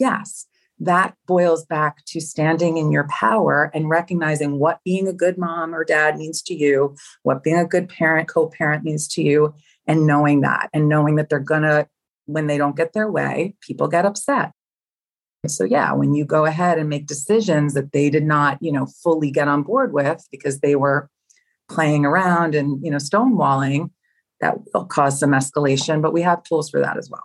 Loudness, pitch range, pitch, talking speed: -19 LUFS, 145-170 Hz, 155 Hz, 200 wpm